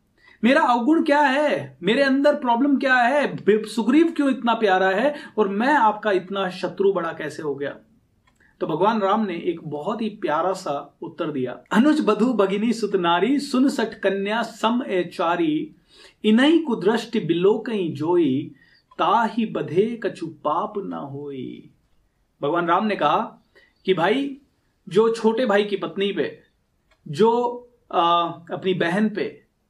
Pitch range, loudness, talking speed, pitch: 180-240 Hz, -21 LUFS, 145 wpm, 210 Hz